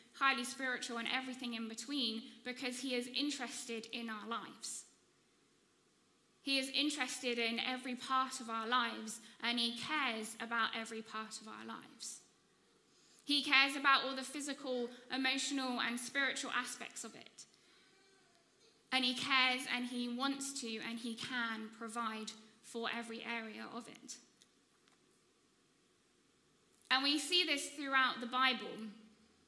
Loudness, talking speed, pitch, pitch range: -37 LUFS, 135 wpm, 250 Hz, 230-270 Hz